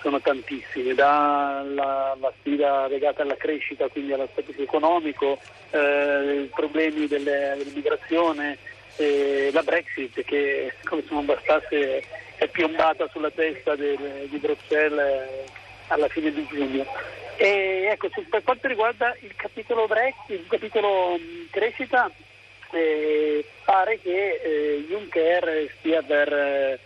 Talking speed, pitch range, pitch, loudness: 120 wpm, 140-195 Hz, 150 Hz, -24 LUFS